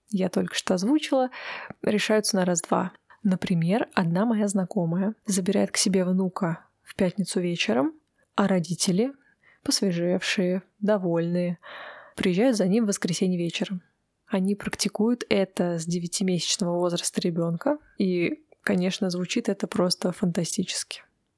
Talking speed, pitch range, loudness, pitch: 115 wpm, 180-215 Hz, -26 LUFS, 195 Hz